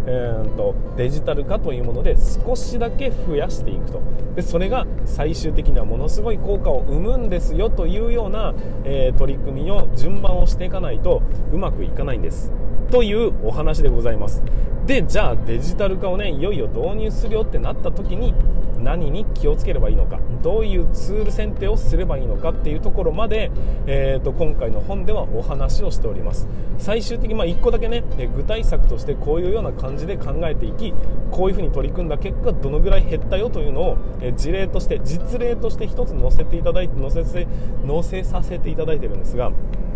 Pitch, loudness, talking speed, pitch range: 135 Hz, -23 LUFS, 395 characters per minute, 125-180 Hz